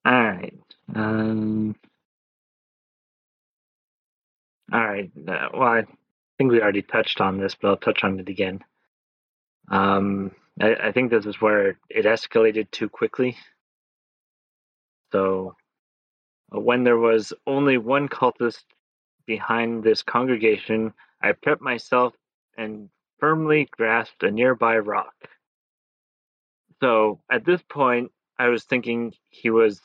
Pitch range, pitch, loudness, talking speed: 105-120 Hz, 115 Hz, -22 LUFS, 120 wpm